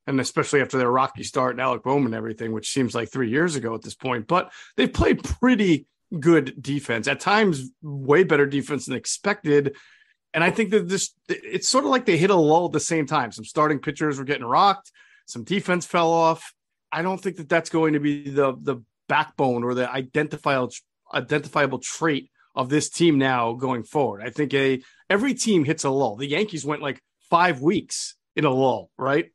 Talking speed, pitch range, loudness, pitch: 205 wpm, 130-175 Hz, -23 LUFS, 150 Hz